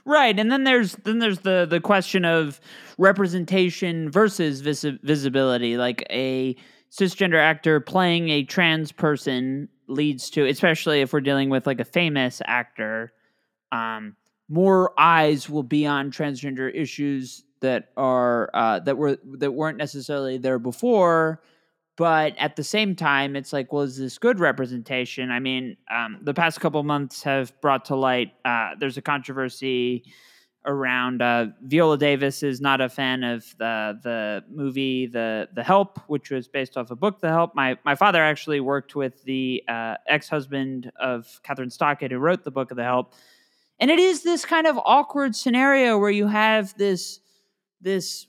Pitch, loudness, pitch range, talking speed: 145 Hz, -22 LUFS, 130-175 Hz, 170 wpm